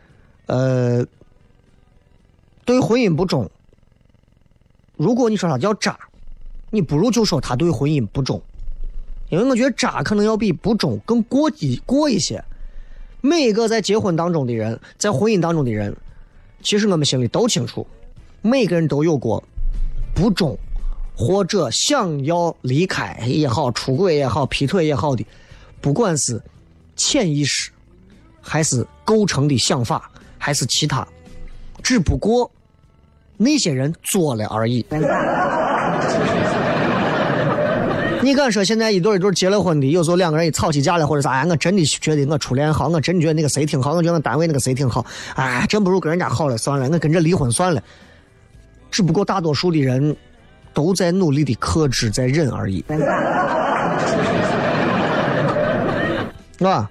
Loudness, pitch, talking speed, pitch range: -18 LUFS, 150 Hz, 225 characters per minute, 120-185 Hz